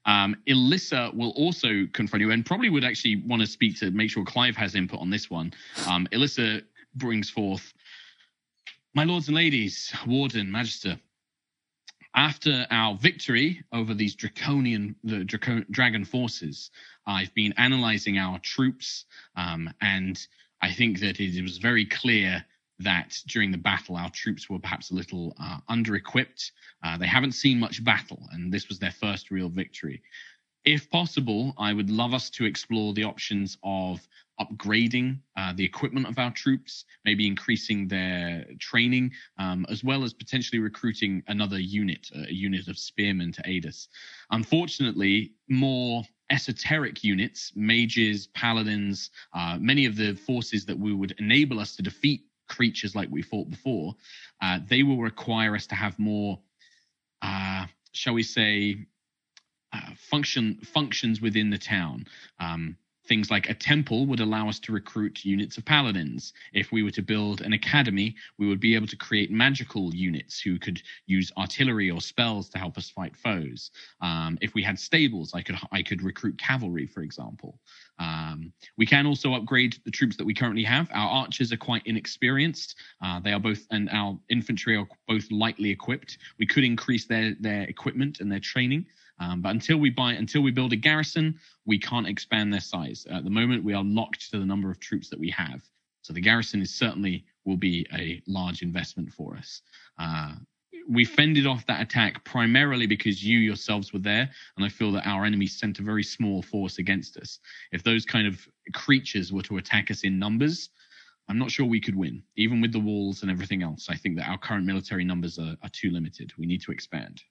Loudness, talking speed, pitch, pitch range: -26 LUFS, 180 wpm, 105 Hz, 95-120 Hz